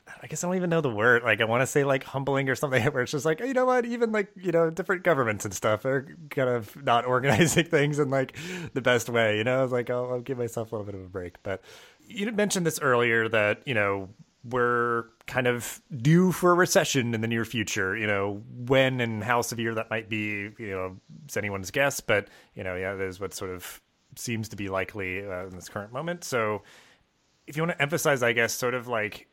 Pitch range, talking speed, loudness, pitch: 110-150 Hz, 250 wpm, -26 LUFS, 125 Hz